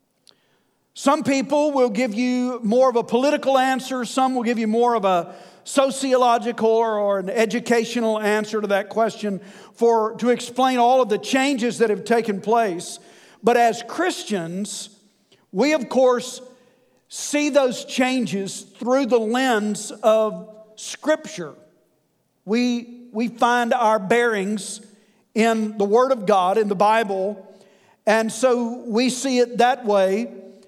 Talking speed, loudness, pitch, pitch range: 135 wpm, -20 LUFS, 230 Hz, 210-250 Hz